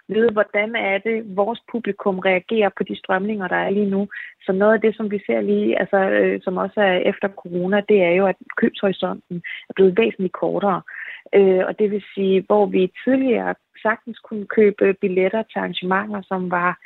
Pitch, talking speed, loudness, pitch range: 200 Hz, 190 wpm, -20 LUFS, 190-215 Hz